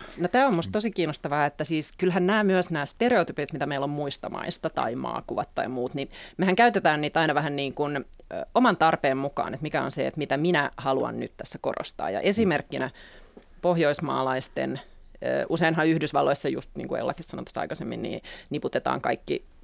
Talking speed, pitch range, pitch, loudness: 175 wpm, 140-180 Hz, 155 Hz, -26 LUFS